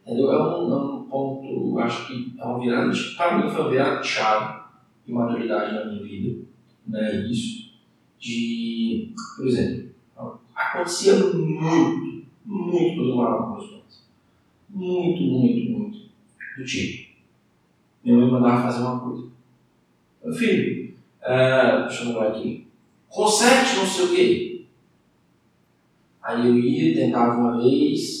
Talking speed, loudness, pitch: 135 wpm, -22 LUFS, 125 Hz